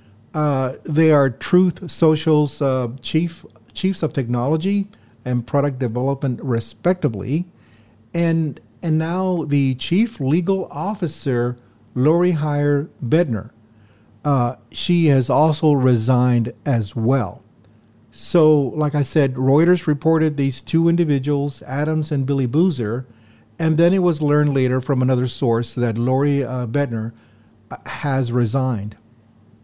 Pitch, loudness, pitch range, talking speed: 140 Hz, -19 LUFS, 120-155 Hz, 120 wpm